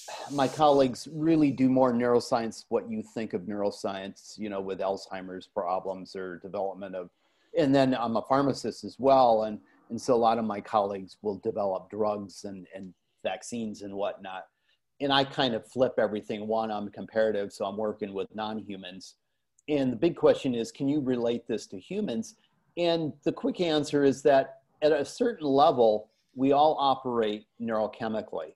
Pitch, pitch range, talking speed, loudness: 115 Hz, 100-140 Hz, 170 wpm, -28 LUFS